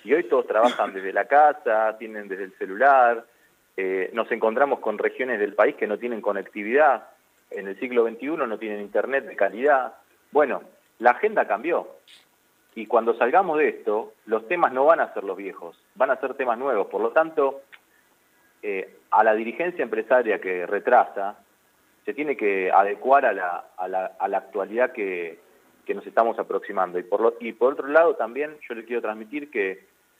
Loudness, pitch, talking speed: -23 LUFS, 150 Hz, 185 wpm